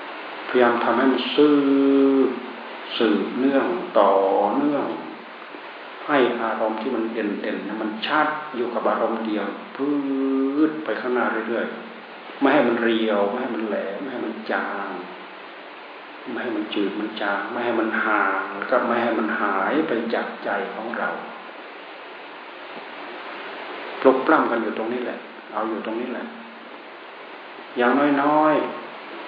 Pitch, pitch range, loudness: 120 Hz, 110-135 Hz, -22 LUFS